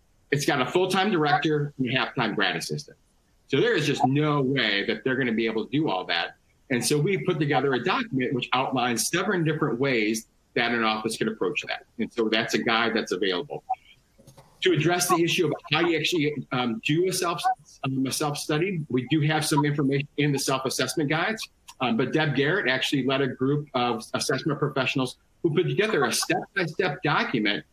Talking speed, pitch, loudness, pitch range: 200 wpm, 140 Hz, -25 LUFS, 125-155 Hz